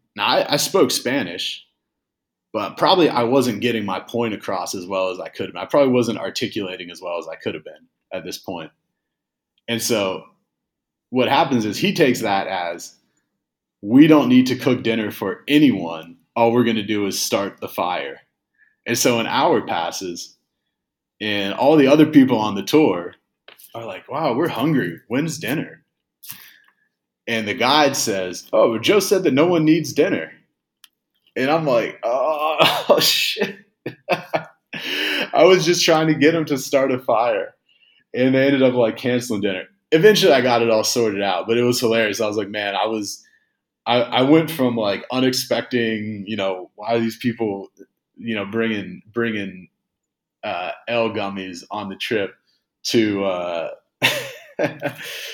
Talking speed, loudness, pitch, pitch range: 170 wpm, -19 LUFS, 115 Hz, 105-130 Hz